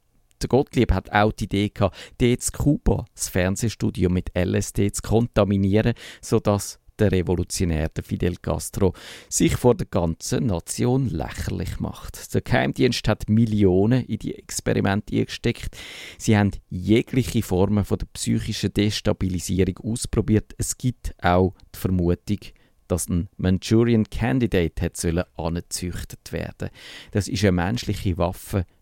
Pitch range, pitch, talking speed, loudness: 90-115 Hz, 100 Hz, 120 wpm, -23 LUFS